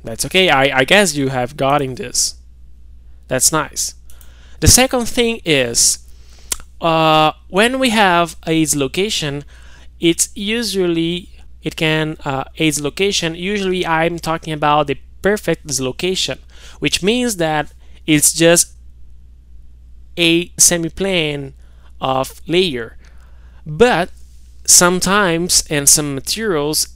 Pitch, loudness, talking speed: 150 Hz, -15 LUFS, 110 wpm